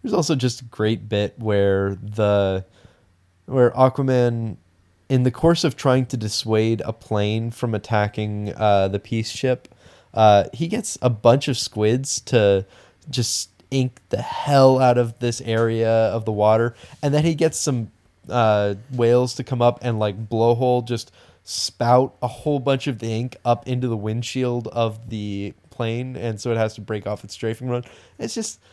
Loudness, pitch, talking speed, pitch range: -21 LUFS, 115 Hz, 175 wpm, 105-125 Hz